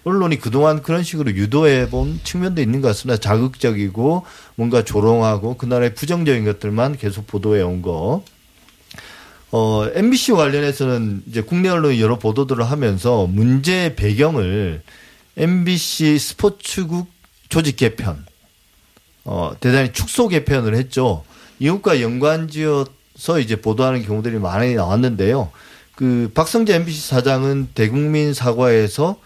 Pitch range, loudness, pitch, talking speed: 110-155 Hz, -18 LUFS, 130 Hz, 305 characters per minute